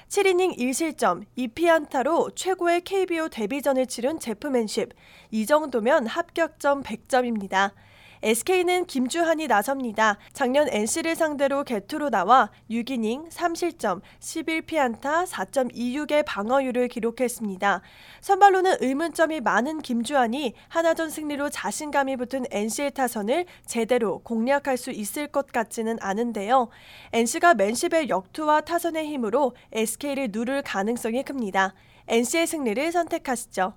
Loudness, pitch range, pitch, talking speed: -24 LUFS, 230-320 Hz, 265 Hz, 290 characters per minute